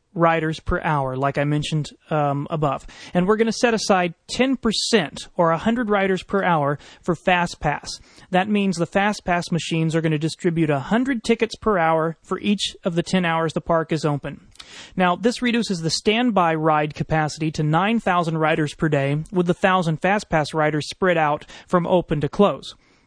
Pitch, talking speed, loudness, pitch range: 170 Hz, 185 wpm, -21 LUFS, 155-195 Hz